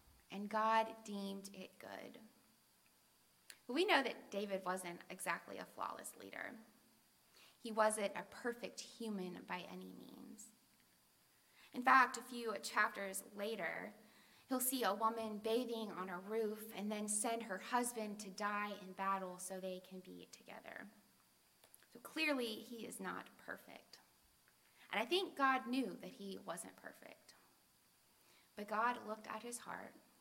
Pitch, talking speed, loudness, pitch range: 220 Hz, 145 wpm, -41 LUFS, 195-240 Hz